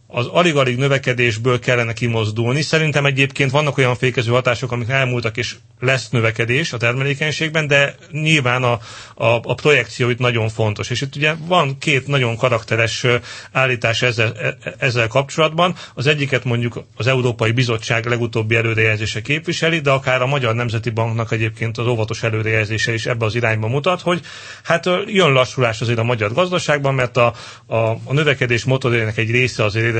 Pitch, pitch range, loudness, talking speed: 125 Hz, 115-140 Hz, -17 LUFS, 160 wpm